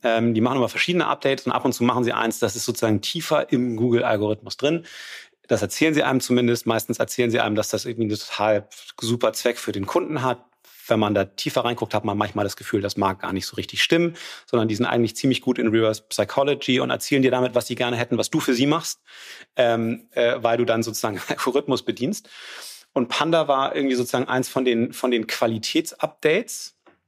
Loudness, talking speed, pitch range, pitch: -22 LUFS, 215 wpm, 115-130 Hz, 120 Hz